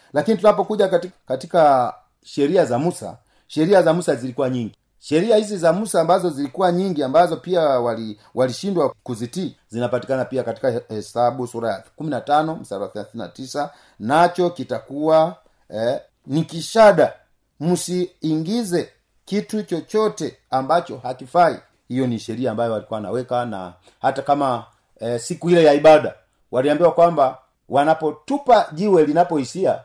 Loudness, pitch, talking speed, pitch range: -19 LUFS, 150 Hz, 125 wpm, 125-175 Hz